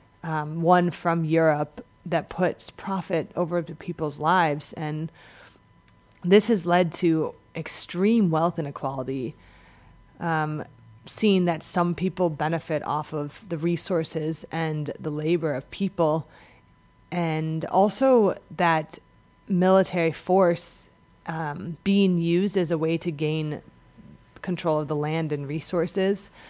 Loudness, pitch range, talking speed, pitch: -25 LUFS, 155-175 Hz, 120 wpm, 165 Hz